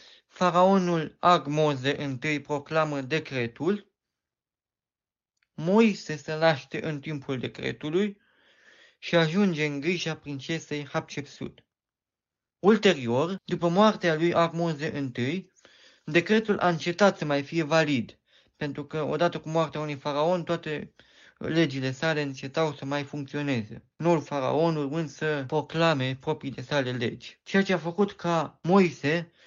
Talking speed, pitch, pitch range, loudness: 120 wpm, 160 Hz, 145-175 Hz, -27 LUFS